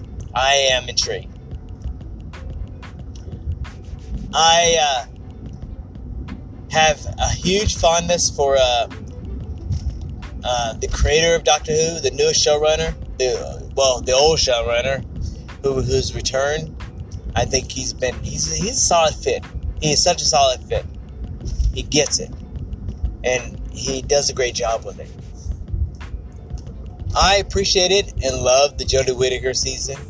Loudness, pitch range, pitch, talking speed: -18 LUFS, 85-135 Hz, 105 Hz, 125 wpm